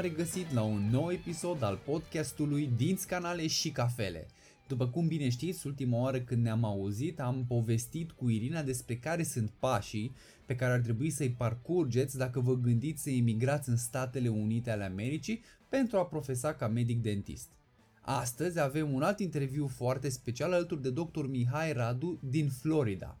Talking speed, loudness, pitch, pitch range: 165 wpm, -33 LUFS, 130 Hz, 120-155 Hz